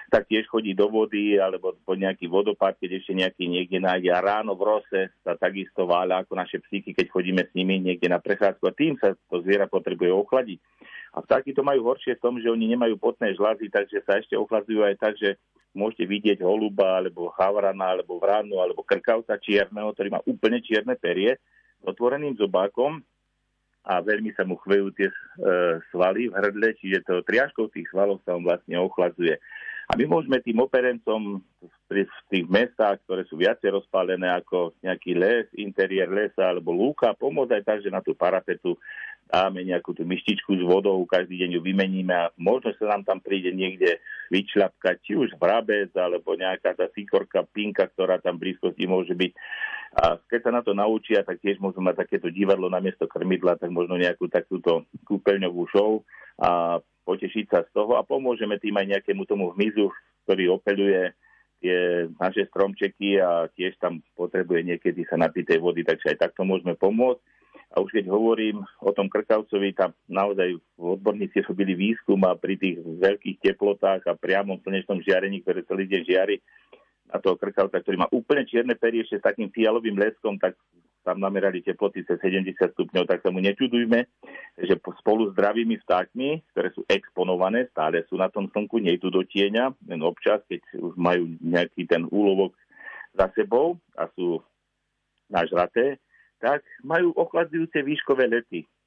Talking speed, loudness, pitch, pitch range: 175 wpm, -24 LUFS, 100 Hz, 90-115 Hz